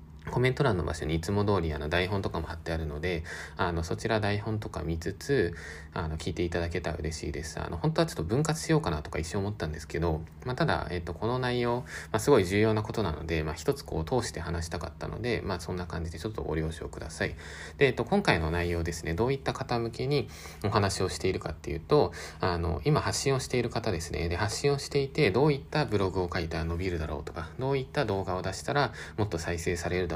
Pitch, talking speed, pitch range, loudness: 90 Hz, 480 characters per minute, 80-115 Hz, -30 LUFS